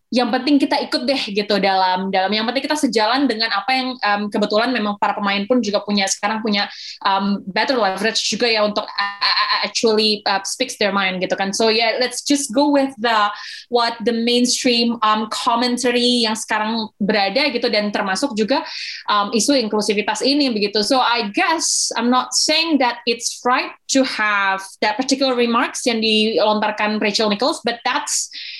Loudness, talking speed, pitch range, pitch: -18 LUFS, 175 wpm, 210-255 Hz, 225 Hz